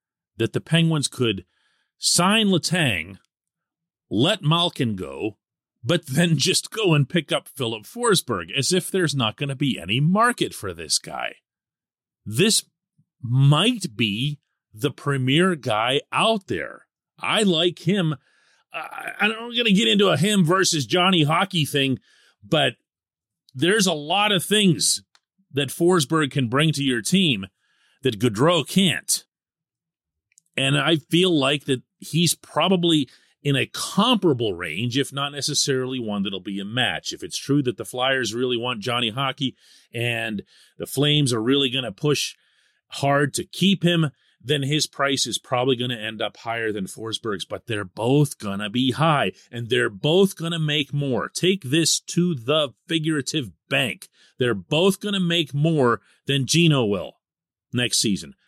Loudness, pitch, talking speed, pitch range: -22 LUFS, 145 Hz, 155 wpm, 125-170 Hz